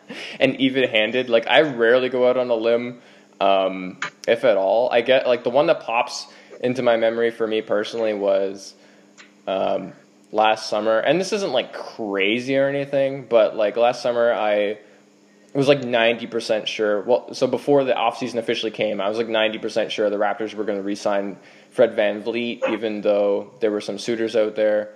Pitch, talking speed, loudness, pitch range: 110 Hz, 190 wpm, -21 LUFS, 105-120 Hz